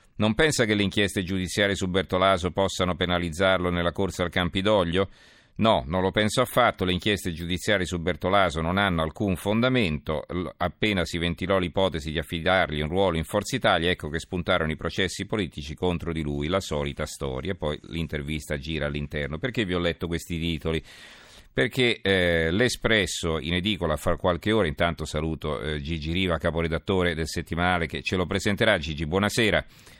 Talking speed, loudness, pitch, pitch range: 165 wpm, -25 LUFS, 90 Hz, 80-100 Hz